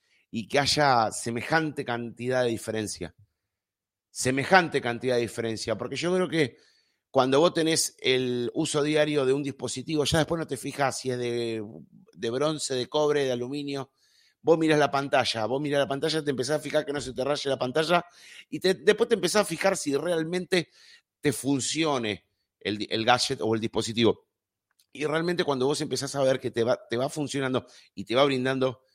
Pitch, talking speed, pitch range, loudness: 135 Hz, 190 wpm, 120-155 Hz, -26 LUFS